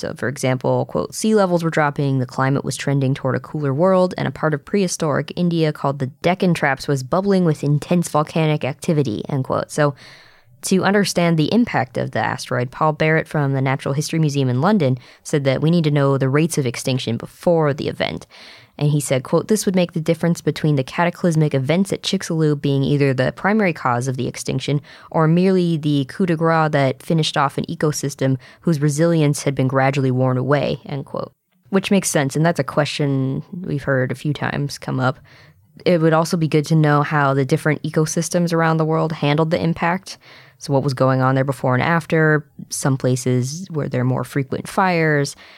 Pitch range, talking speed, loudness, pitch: 135-165 Hz, 205 wpm, -19 LUFS, 150 Hz